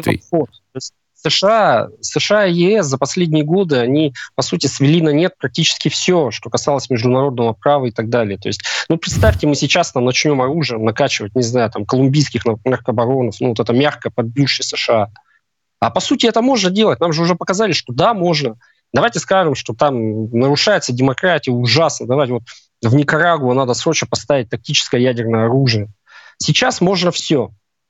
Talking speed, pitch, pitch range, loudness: 165 wpm, 140 Hz, 120-165 Hz, -15 LUFS